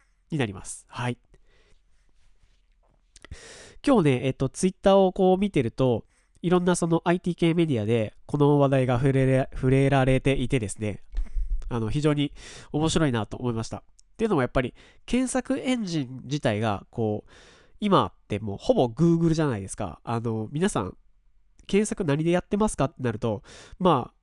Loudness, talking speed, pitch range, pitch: -25 LUFS, 320 characters per minute, 110-170 Hz, 135 Hz